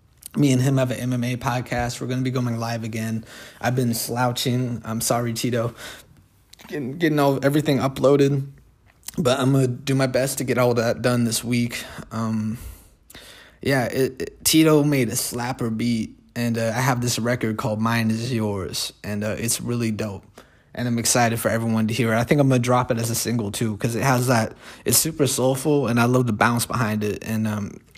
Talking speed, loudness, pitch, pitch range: 205 wpm, -22 LUFS, 120 Hz, 115-130 Hz